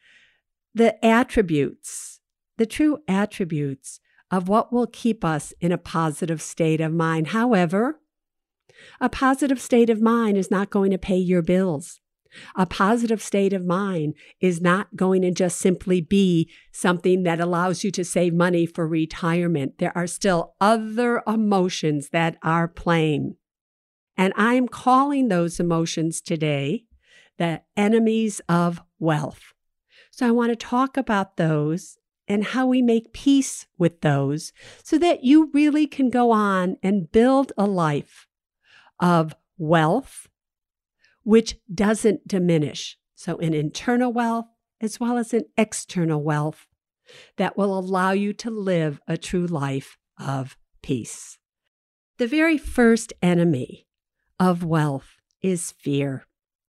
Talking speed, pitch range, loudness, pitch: 135 wpm, 165-230 Hz, -22 LUFS, 190 Hz